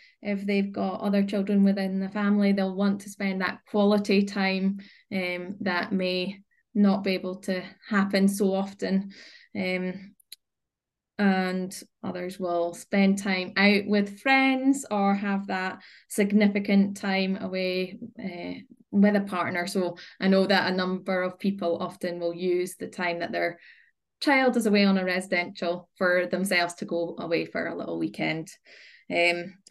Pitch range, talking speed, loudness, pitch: 180-205 Hz, 150 wpm, -26 LUFS, 195 Hz